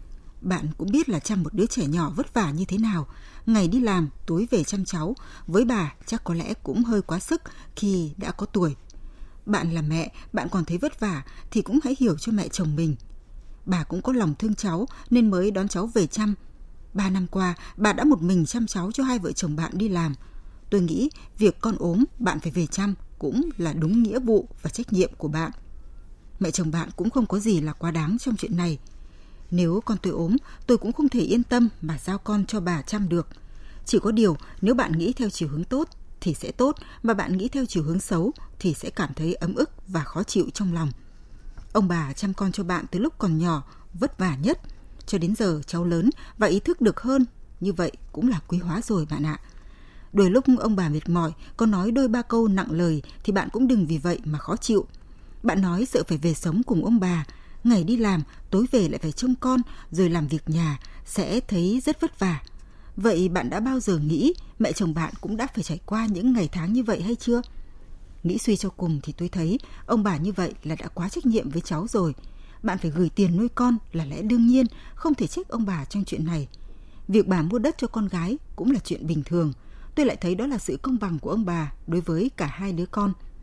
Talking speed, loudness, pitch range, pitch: 235 wpm, -25 LUFS, 165-230 Hz, 190 Hz